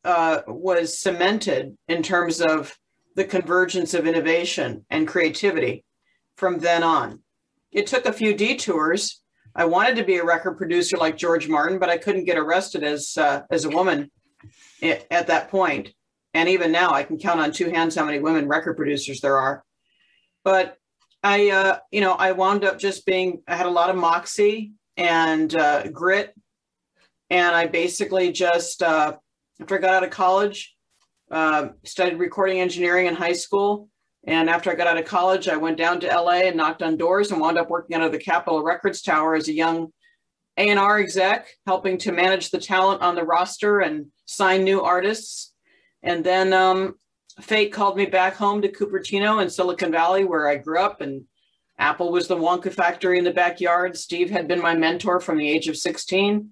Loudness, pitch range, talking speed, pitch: -21 LUFS, 165-190 Hz, 185 wpm, 180 Hz